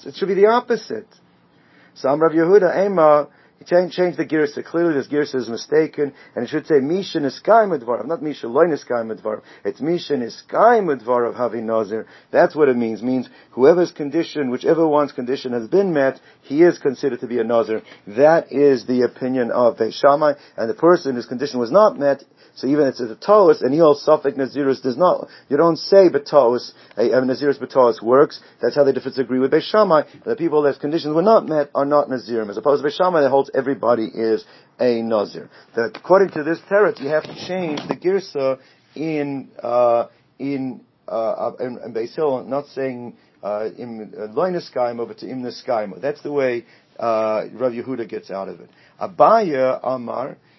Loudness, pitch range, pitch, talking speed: -19 LUFS, 125-160 Hz, 140 Hz, 185 wpm